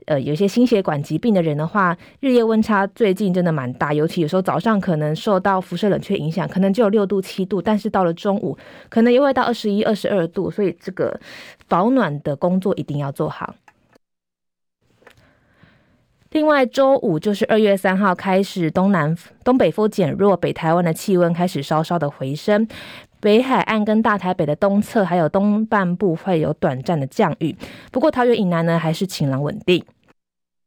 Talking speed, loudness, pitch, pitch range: 285 characters per minute, -19 LUFS, 190 Hz, 160-210 Hz